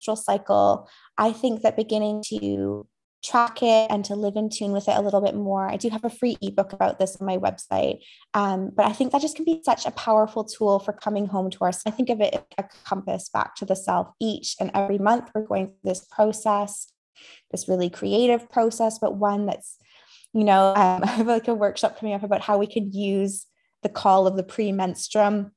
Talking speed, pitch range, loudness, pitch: 220 wpm, 195-220 Hz, -23 LUFS, 205 Hz